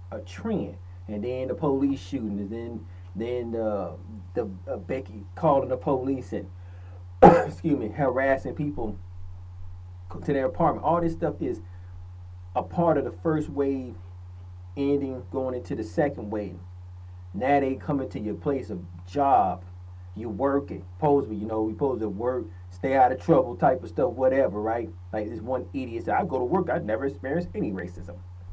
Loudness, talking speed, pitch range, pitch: -26 LUFS, 170 wpm, 90-130 Hz, 105 Hz